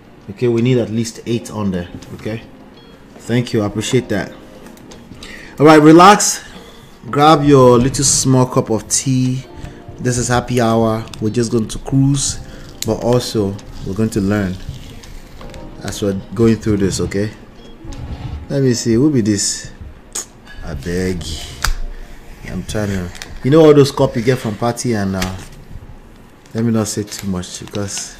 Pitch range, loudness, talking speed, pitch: 100-125 Hz, -15 LUFS, 160 wpm, 110 Hz